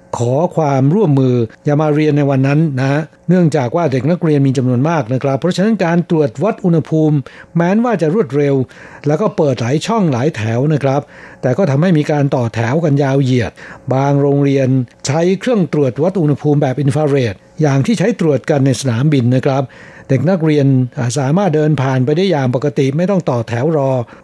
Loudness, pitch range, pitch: -14 LUFS, 135-165 Hz, 145 Hz